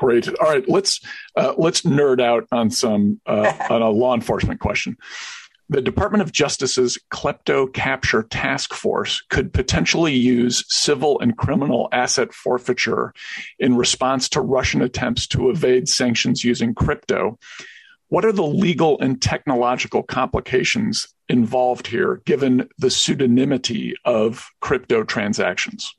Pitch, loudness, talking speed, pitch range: 130 Hz, -19 LUFS, 130 wpm, 125-190 Hz